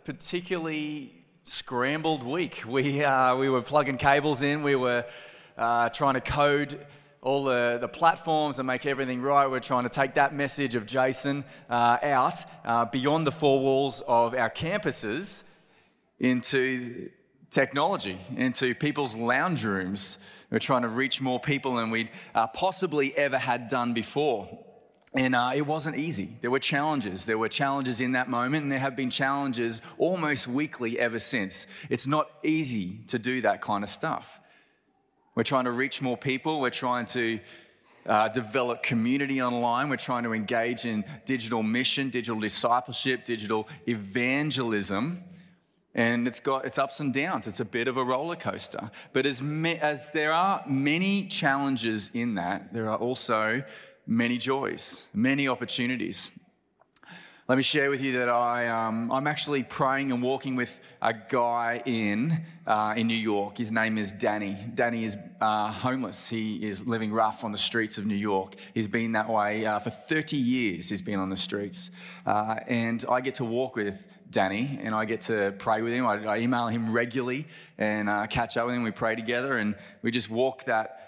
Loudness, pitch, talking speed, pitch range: -27 LUFS, 125 Hz, 175 wpm, 115-140 Hz